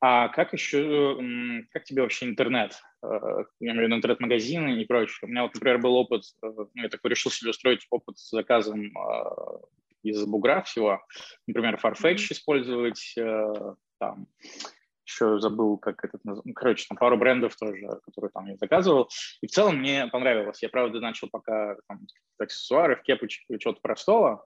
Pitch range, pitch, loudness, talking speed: 110-130 Hz, 120 Hz, -26 LUFS, 160 wpm